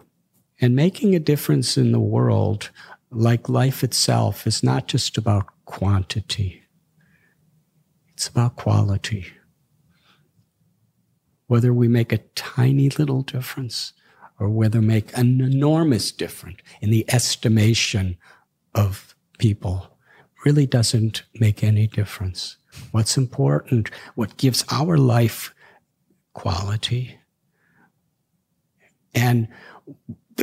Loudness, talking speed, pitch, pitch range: -21 LUFS, 95 wpm, 120 Hz, 110-135 Hz